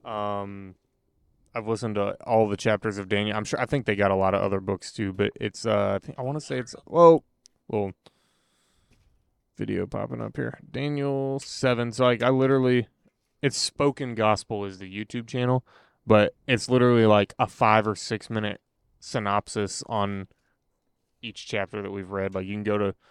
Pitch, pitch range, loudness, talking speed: 110 Hz, 100-125 Hz, -25 LUFS, 185 wpm